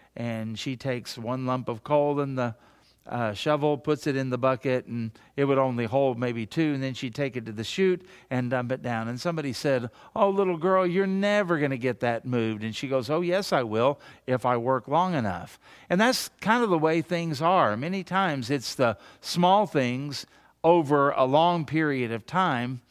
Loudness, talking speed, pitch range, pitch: -26 LUFS, 210 wpm, 125-170 Hz, 135 Hz